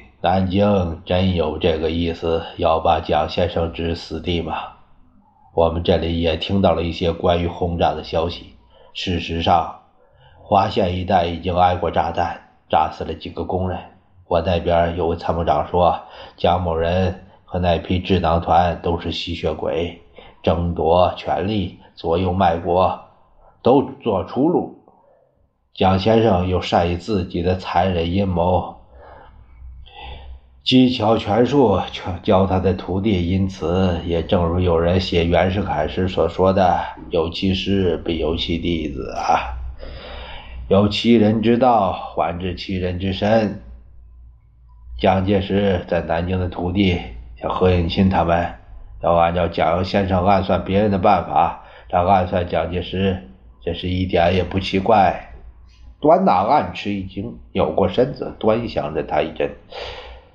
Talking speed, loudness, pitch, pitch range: 205 characters per minute, -19 LUFS, 90 Hz, 85-95 Hz